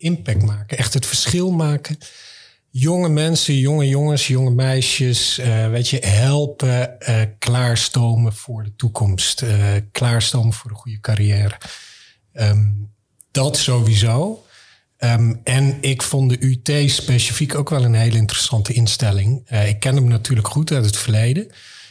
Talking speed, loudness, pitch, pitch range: 140 wpm, -17 LUFS, 125 Hz, 110-135 Hz